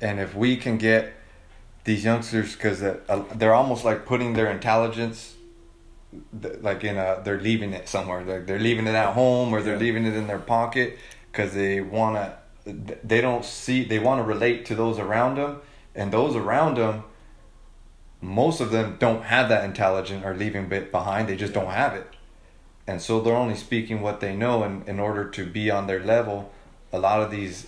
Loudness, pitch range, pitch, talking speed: -24 LUFS, 100-115 Hz, 110 Hz, 190 wpm